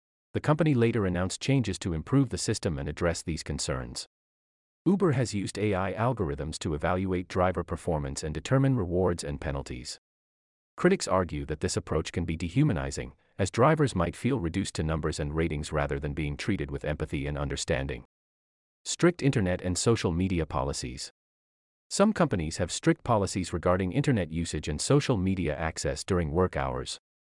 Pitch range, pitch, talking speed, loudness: 75-105 Hz, 90 Hz, 160 wpm, -29 LUFS